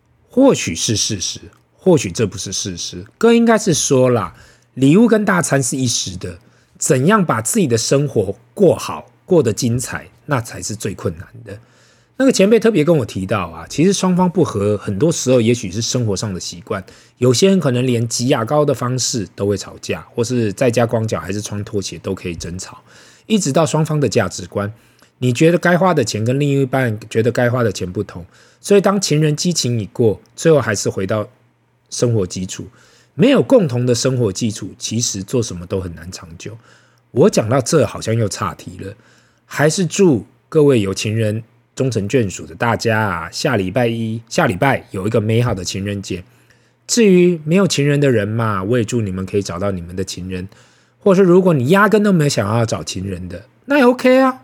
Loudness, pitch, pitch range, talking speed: -16 LUFS, 115 Hz, 100-145 Hz, 290 characters per minute